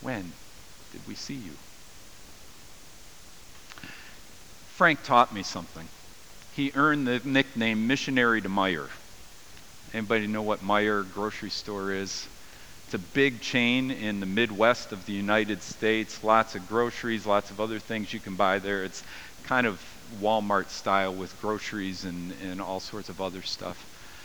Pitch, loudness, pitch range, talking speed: 105 Hz, -27 LUFS, 95-115 Hz, 145 wpm